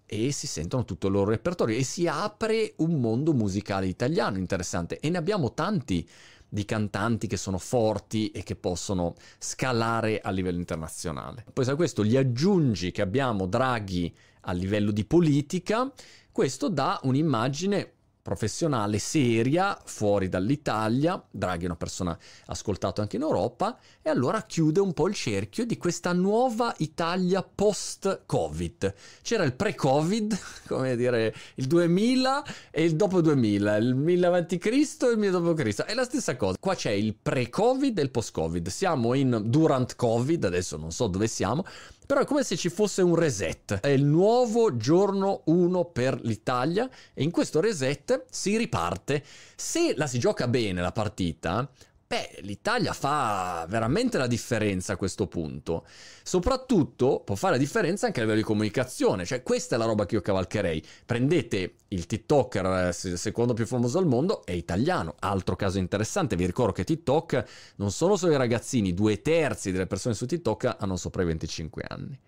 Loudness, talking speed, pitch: -27 LUFS, 165 wpm, 125 Hz